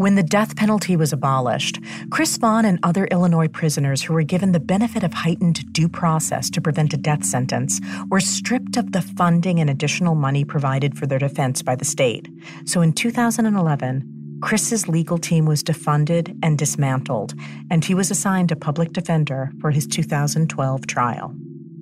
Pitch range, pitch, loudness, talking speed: 145-185 Hz, 160 Hz, -20 LUFS, 170 wpm